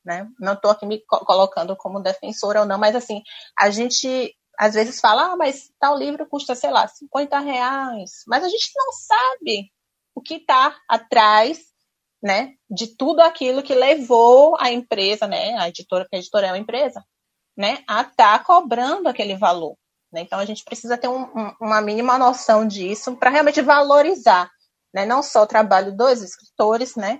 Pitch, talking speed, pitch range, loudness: 240 Hz, 180 wpm, 210-280 Hz, -18 LUFS